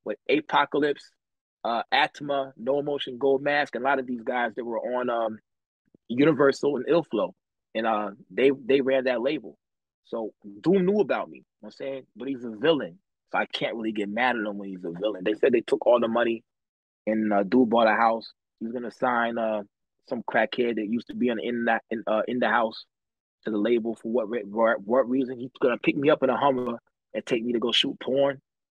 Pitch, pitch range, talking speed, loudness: 120 Hz, 110-135 Hz, 230 wpm, -26 LUFS